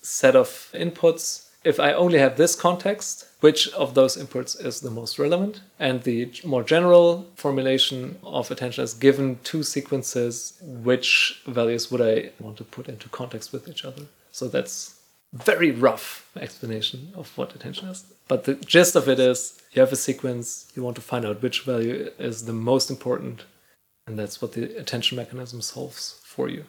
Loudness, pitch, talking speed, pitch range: -22 LUFS, 130 Hz, 180 wpm, 120-155 Hz